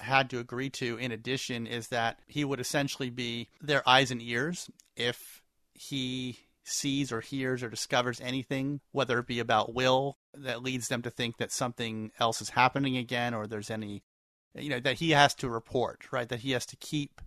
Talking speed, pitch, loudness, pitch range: 195 wpm, 125 Hz, -31 LUFS, 115-135 Hz